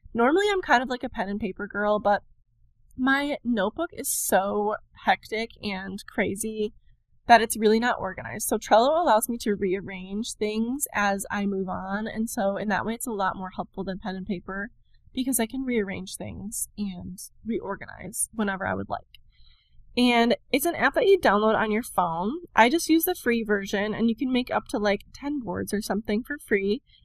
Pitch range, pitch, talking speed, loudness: 200-245 Hz, 215 Hz, 195 wpm, -26 LUFS